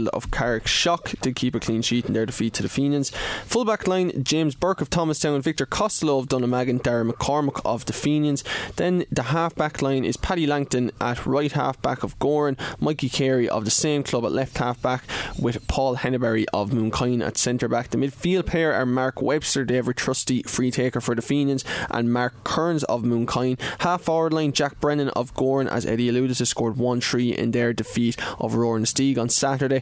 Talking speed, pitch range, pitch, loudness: 205 wpm, 120-150 Hz, 130 Hz, -23 LUFS